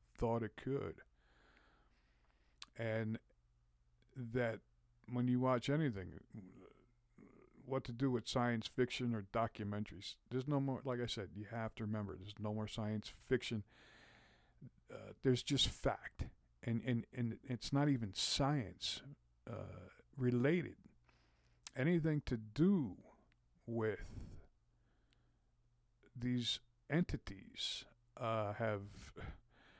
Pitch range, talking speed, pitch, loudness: 105-125 Hz, 105 wpm, 115 Hz, -41 LUFS